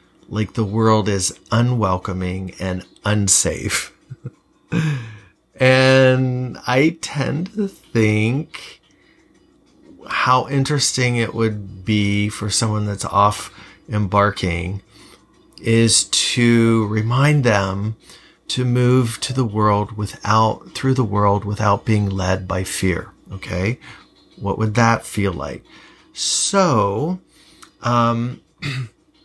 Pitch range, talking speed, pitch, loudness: 100-130 Hz, 100 wpm, 110 Hz, -18 LUFS